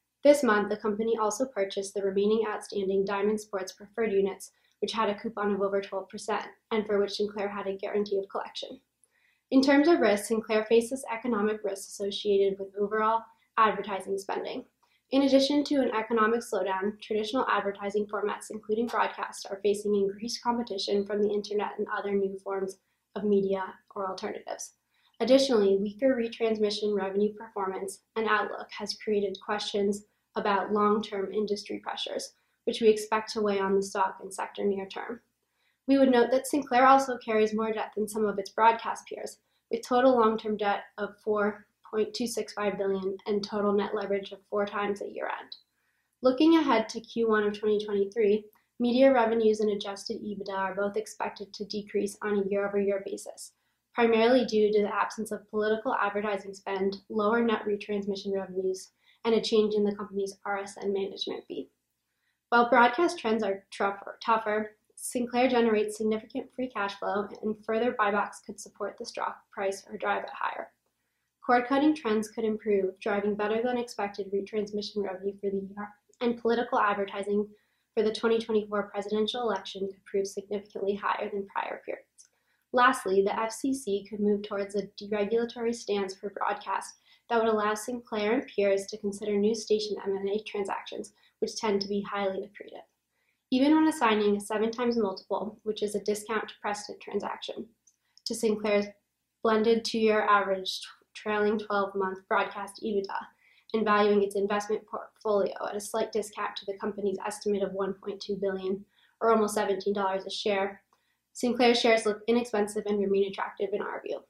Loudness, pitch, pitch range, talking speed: -29 LUFS, 210 Hz, 200-225 Hz, 160 wpm